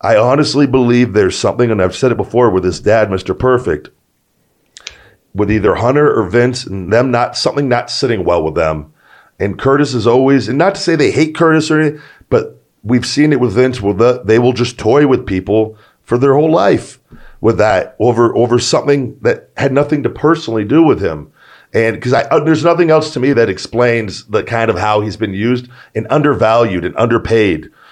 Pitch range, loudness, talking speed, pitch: 110-140 Hz, -13 LUFS, 205 wpm, 120 Hz